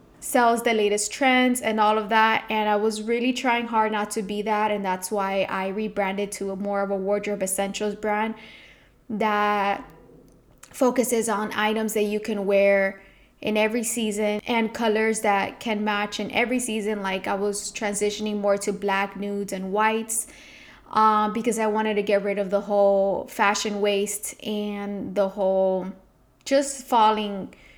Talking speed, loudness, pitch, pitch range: 165 wpm, -24 LUFS, 210 Hz, 200-220 Hz